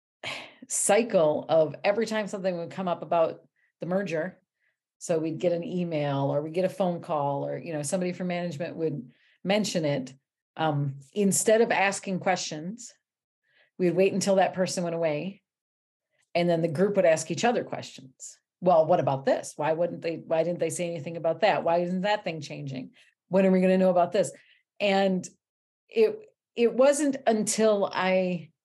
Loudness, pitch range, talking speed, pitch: -26 LUFS, 160-195 Hz, 180 wpm, 180 Hz